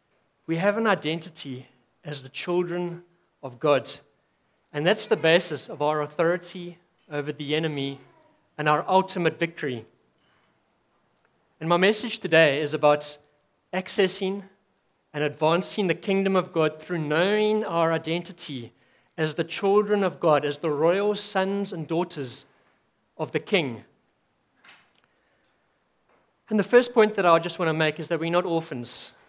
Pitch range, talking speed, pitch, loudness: 150-185 Hz, 140 wpm, 165 Hz, -25 LUFS